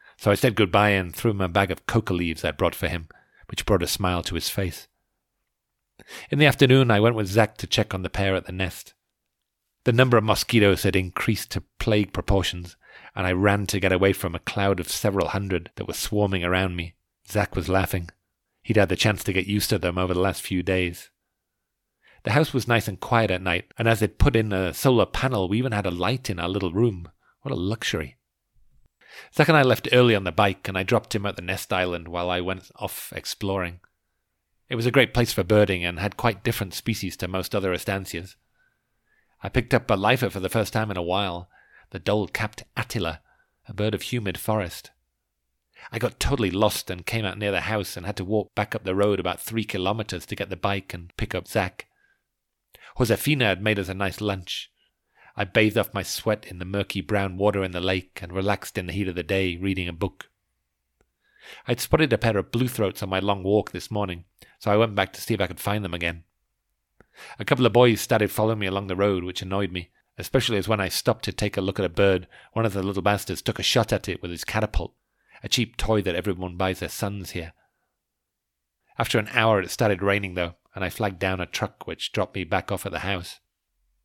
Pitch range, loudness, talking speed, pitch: 90-110 Hz, -24 LUFS, 230 wpm, 100 Hz